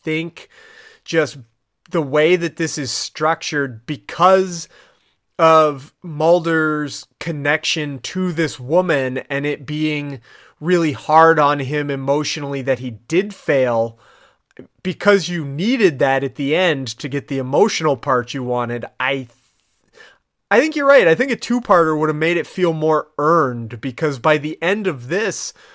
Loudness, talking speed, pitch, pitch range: -18 LUFS, 150 wpm, 155 Hz, 135-170 Hz